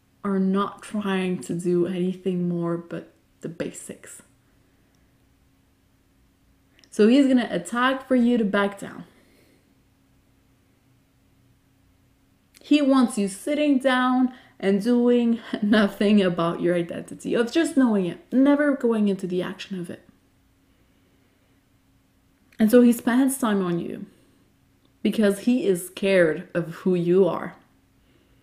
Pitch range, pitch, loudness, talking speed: 185-245 Hz, 205 Hz, -22 LUFS, 120 wpm